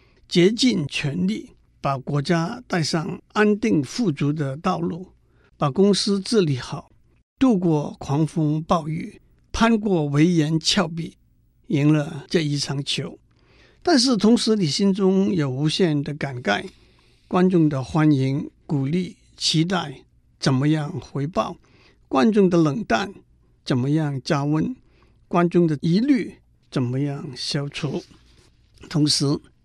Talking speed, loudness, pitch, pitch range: 180 characters per minute, -22 LUFS, 160 Hz, 145-185 Hz